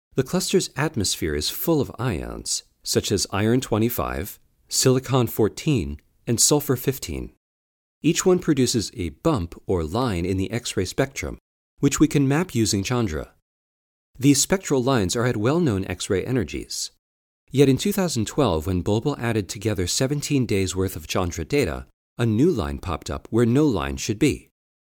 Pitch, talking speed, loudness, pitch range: 110 Hz, 160 wpm, -23 LUFS, 85-135 Hz